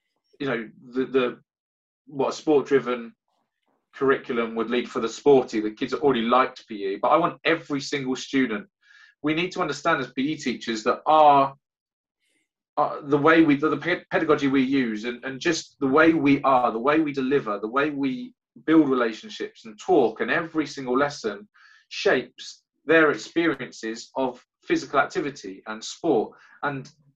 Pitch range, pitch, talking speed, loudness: 125-160 Hz, 140 Hz, 165 wpm, -23 LUFS